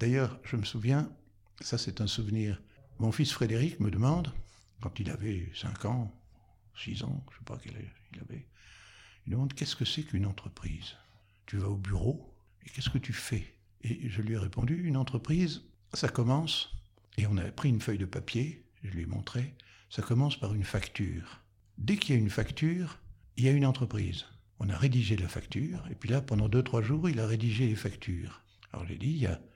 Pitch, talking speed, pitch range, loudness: 110 Hz, 210 wpm, 100-130 Hz, -33 LUFS